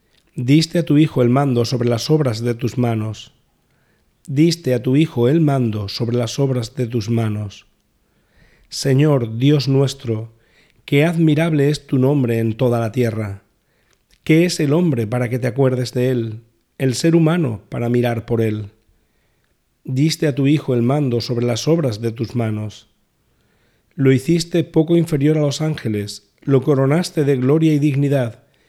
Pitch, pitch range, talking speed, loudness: 130 Hz, 115-150 Hz, 165 wpm, -18 LUFS